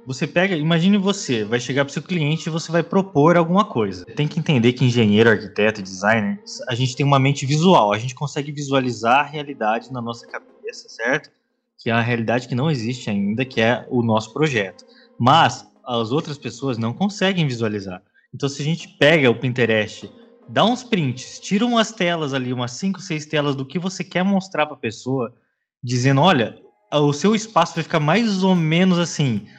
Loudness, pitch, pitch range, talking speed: -20 LUFS, 145 Hz, 120-175 Hz, 195 wpm